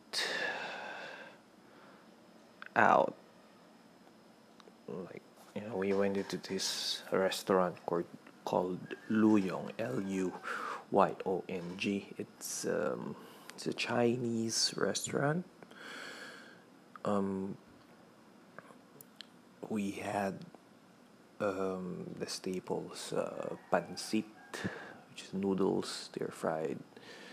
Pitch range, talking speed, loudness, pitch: 95-105 Hz, 70 wpm, -35 LUFS, 100 Hz